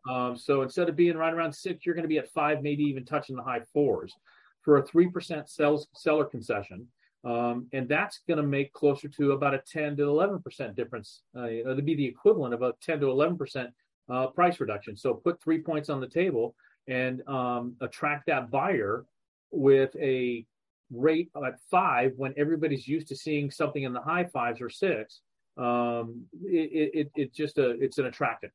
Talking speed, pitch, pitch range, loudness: 195 wpm, 145 Hz, 125-155 Hz, -29 LUFS